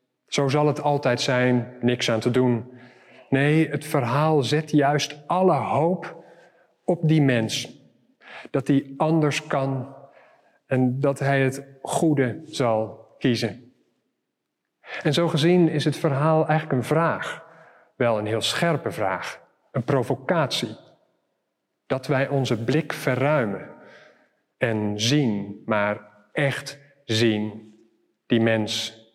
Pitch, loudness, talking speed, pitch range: 135 Hz, -23 LUFS, 120 wpm, 120-150 Hz